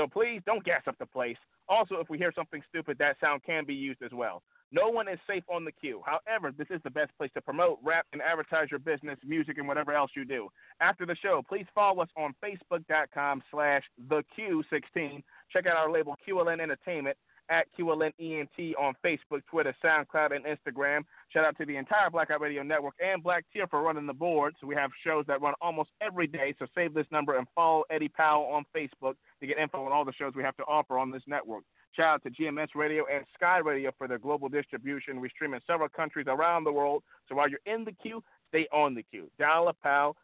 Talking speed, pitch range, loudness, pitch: 230 wpm, 145-170 Hz, -31 LUFS, 155 Hz